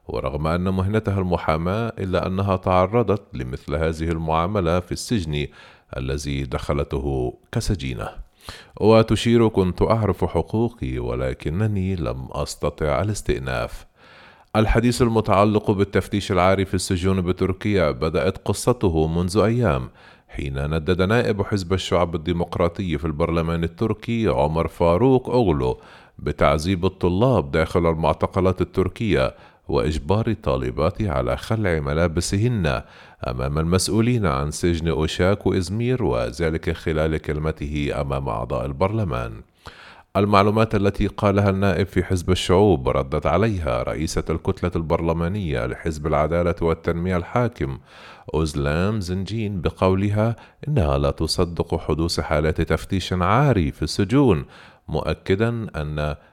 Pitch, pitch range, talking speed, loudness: 90 Hz, 80-100 Hz, 105 wpm, -22 LUFS